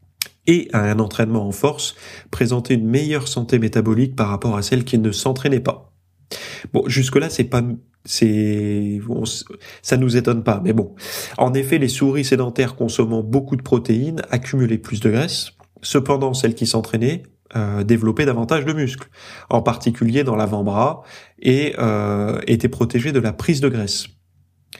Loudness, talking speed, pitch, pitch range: -19 LUFS, 160 wpm, 120 Hz, 110-135 Hz